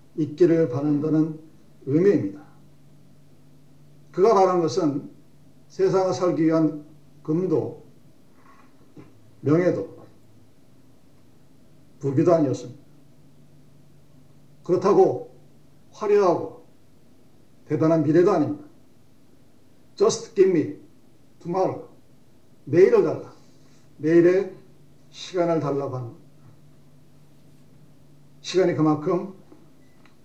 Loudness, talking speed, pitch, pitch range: -22 LUFS, 185 characters per minute, 145 Hz, 140-165 Hz